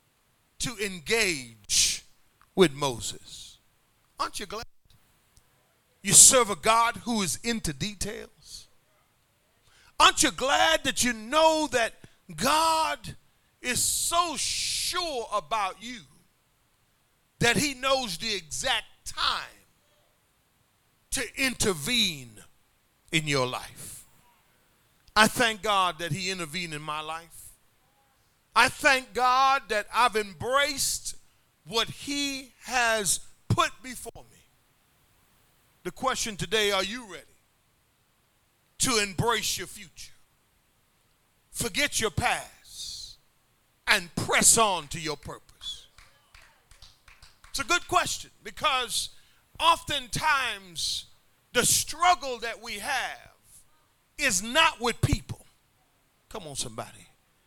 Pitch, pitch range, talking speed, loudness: 215 Hz, 160-260 Hz, 100 wpm, -25 LUFS